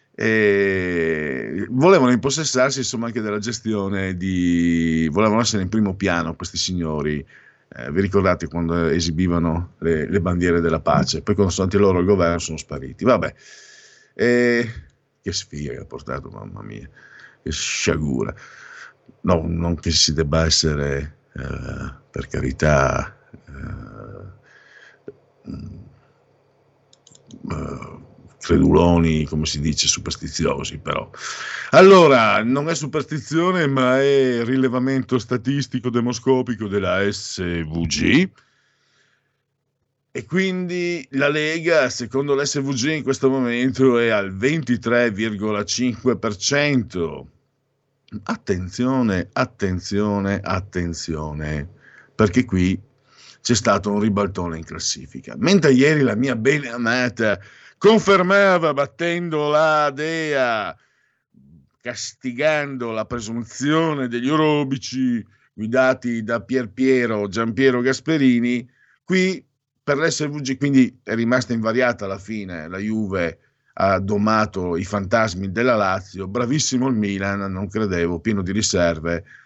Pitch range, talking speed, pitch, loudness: 95-130 Hz, 110 wpm, 115 Hz, -20 LUFS